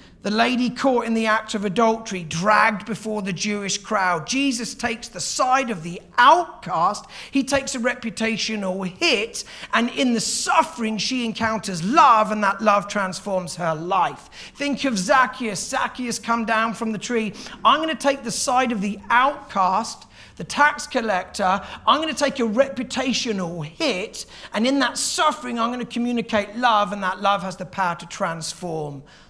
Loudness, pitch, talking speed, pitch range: -21 LUFS, 225 Hz, 170 wpm, 200-250 Hz